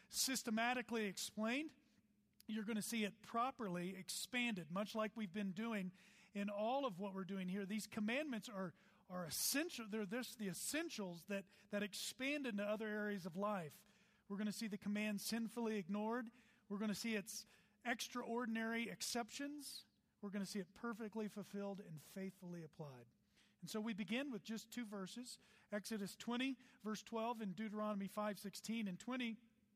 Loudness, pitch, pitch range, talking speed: -45 LUFS, 215 Hz, 200-230 Hz, 165 wpm